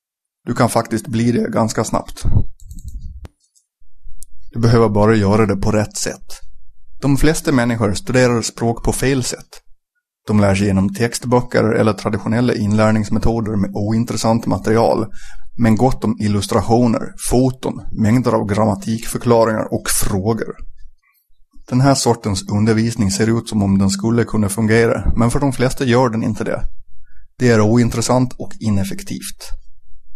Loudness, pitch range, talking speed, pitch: -17 LUFS, 100-120 Hz, 135 wpm, 110 Hz